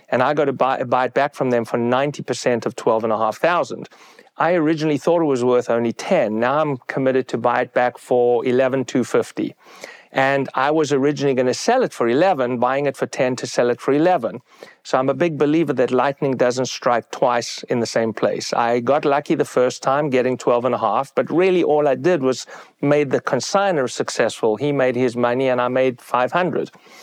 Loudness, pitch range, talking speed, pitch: -19 LUFS, 125-145 Hz, 215 wpm, 130 Hz